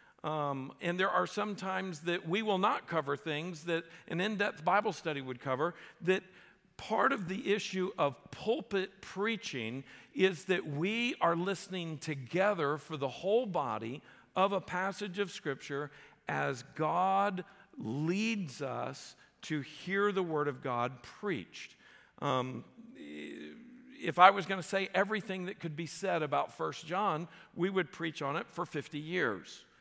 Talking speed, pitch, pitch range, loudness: 155 wpm, 180 Hz, 150-195 Hz, -34 LUFS